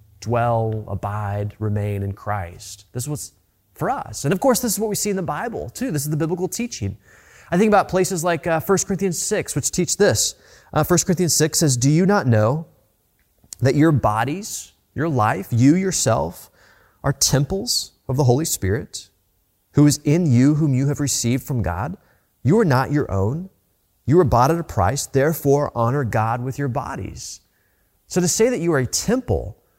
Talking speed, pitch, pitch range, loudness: 195 wpm, 140 Hz, 105-170 Hz, -20 LUFS